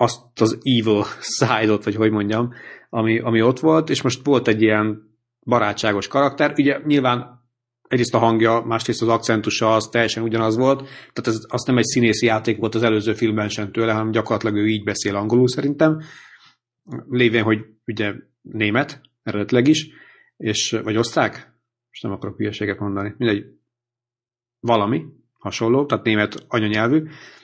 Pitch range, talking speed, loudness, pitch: 110-120 Hz, 155 wpm, -20 LUFS, 115 Hz